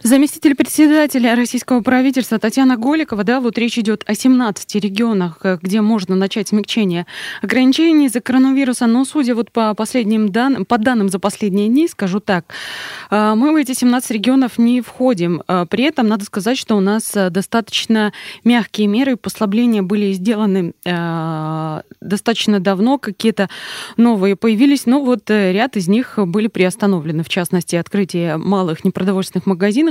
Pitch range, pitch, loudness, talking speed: 195-250 Hz, 220 Hz, -16 LUFS, 145 wpm